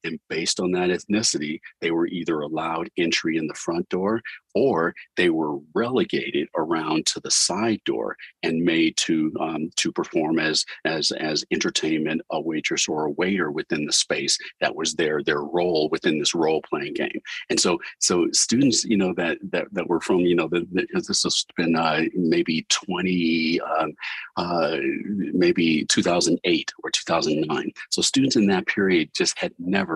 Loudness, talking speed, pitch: -23 LUFS, 180 wpm, 175 Hz